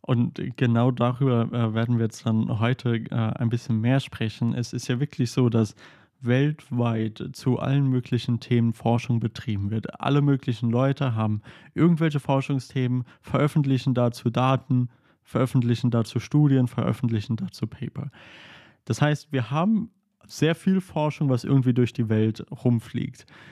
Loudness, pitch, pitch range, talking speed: -25 LUFS, 125 Hz, 115-135 Hz, 140 wpm